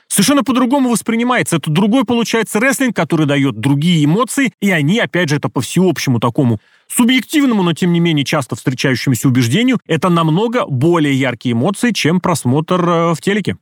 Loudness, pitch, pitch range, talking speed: -14 LUFS, 170 Hz, 145-225 Hz, 160 wpm